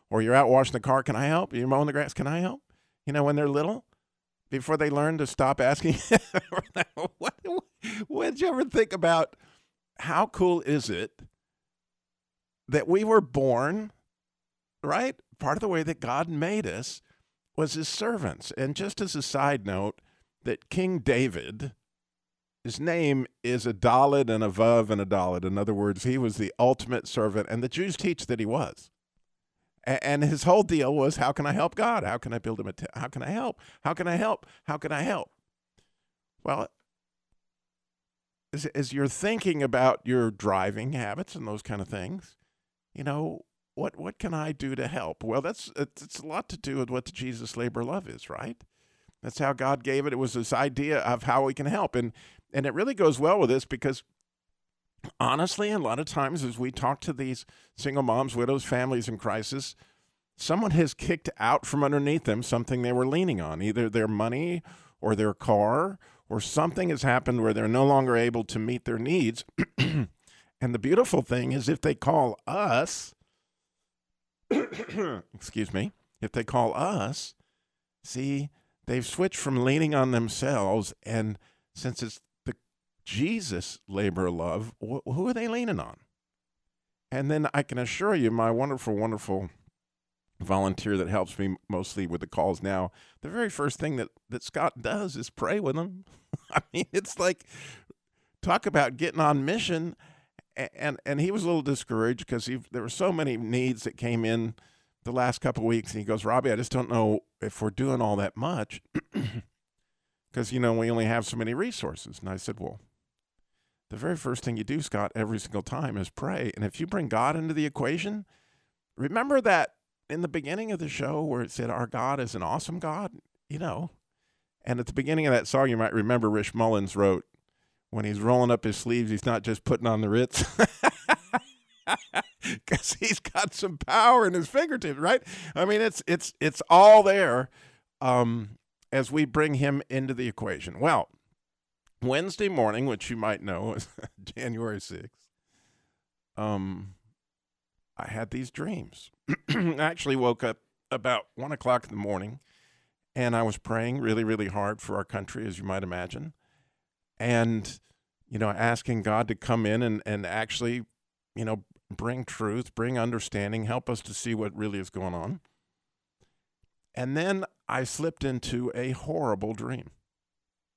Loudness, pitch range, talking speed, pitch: -28 LUFS, 110-150 Hz, 175 wpm, 125 Hz